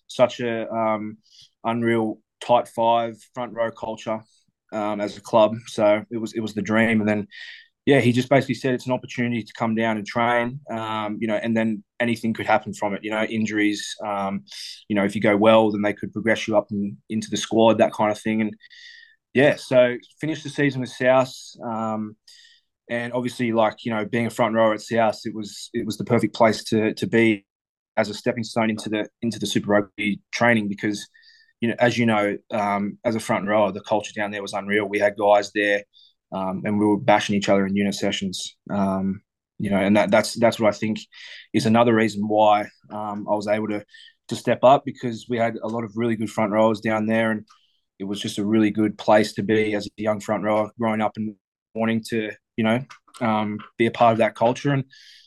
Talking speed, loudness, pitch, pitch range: 225 wpm, -22 LUFS, 110 Hz, 105-115 Hz